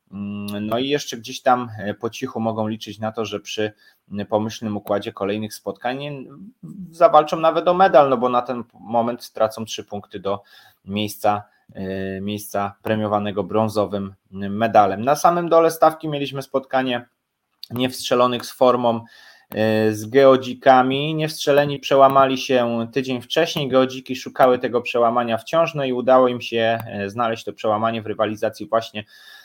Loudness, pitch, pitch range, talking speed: -20 LUFS, 120 Hz, 105-135 Hz, 135 wpm